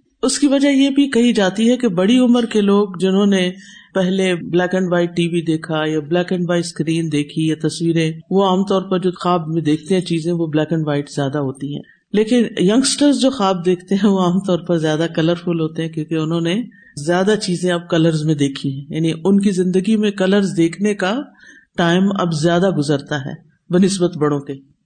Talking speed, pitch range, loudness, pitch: 210 wpm, 160-200 Hz, -17 LUFS, 180 Hz